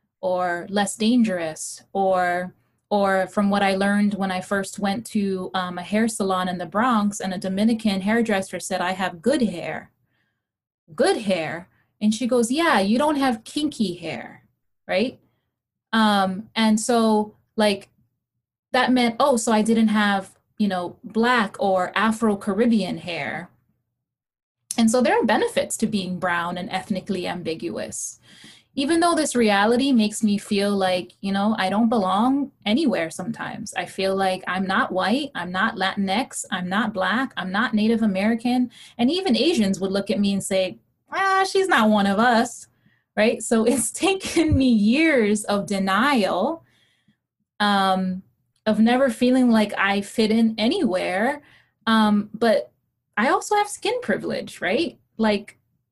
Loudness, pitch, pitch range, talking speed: -22 LUFS, 210 Hz, 190-235 Hz, 155 wpm